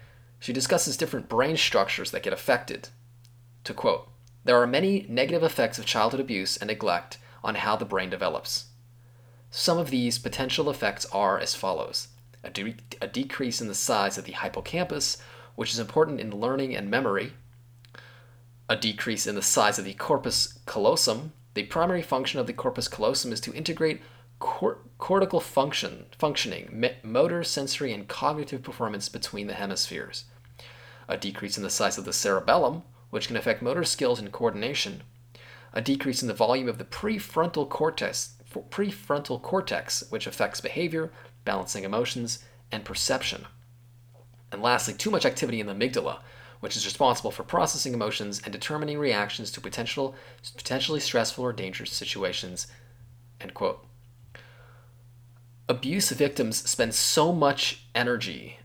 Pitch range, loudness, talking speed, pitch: 120-135 Hz, -27 LUFS, 150 wpm, 120 Hz